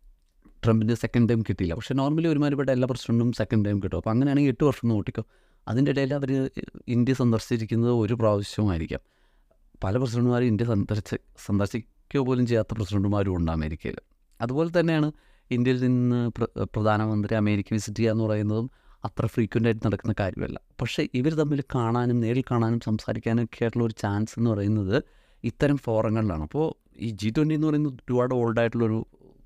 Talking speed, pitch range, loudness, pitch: 140 wpm, 105-130 Hz, -26 LUFS, 115 Hz